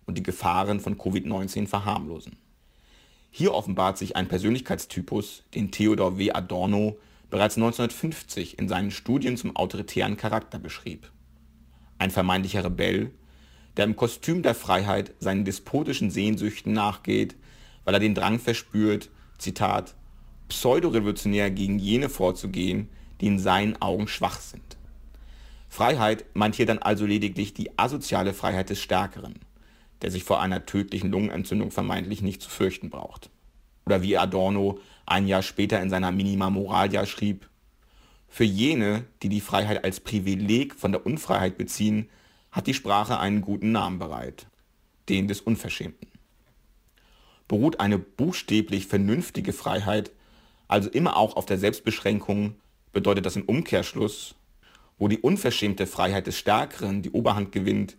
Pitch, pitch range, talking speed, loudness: 100 Hz, 90-105 Hz, 135 wpm, -26 LUFS